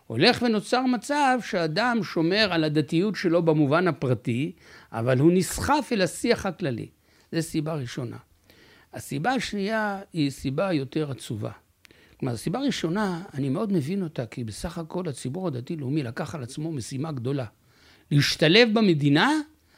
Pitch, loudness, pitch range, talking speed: 165 Hz, -25 LUFS, 135-200 Hz, 135 wpm